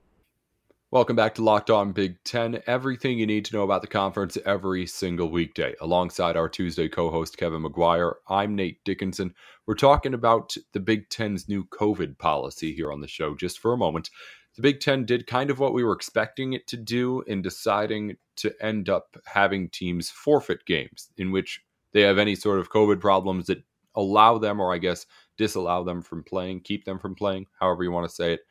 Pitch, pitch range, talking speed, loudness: 100 Hz, 90-110 Hz, 200 wpm, -25 LUFS